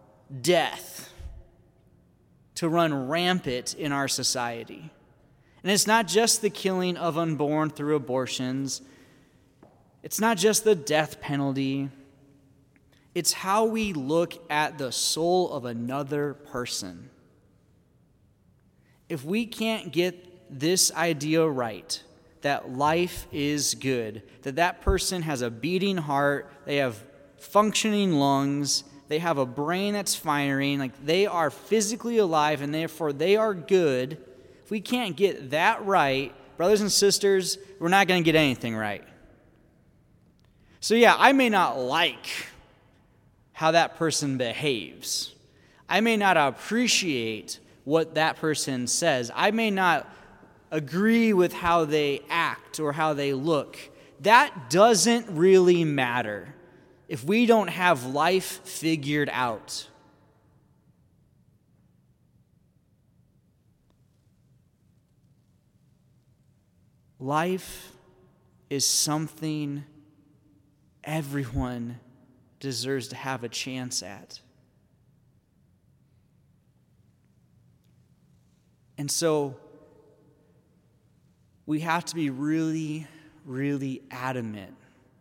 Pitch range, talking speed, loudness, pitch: 135-180 Hz, 105 wpm, -25 LUFS, 150 Hz